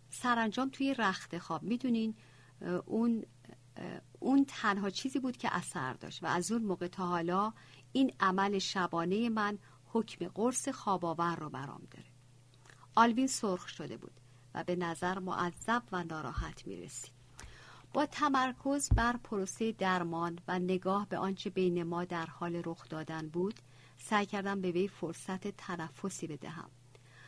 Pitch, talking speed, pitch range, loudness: 180 Hz, 140 wpm, 160-220 Hz, -35 LUFS